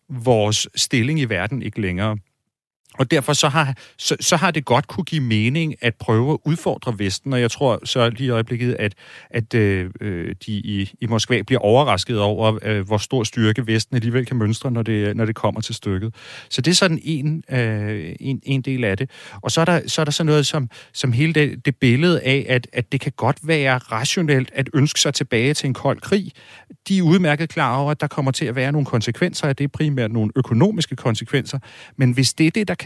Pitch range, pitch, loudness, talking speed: 110-150 Hz, 130 Hz, -20 LUFS, 225 wpm